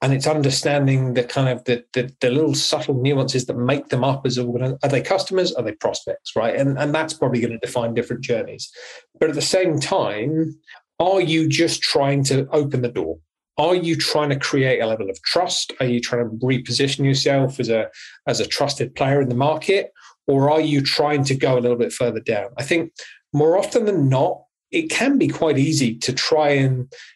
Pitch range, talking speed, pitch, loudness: 125-155 Hz, 210 wpm, 140 Hz, -20 LUFS